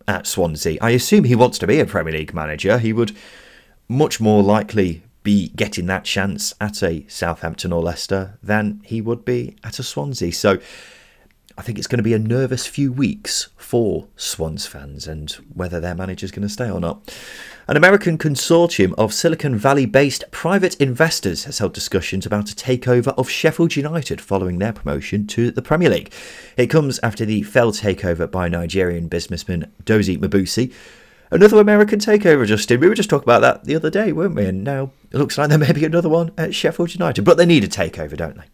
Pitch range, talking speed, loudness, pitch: 95-140 Hz, 200 wpm, -18 LUFS, 110 Hz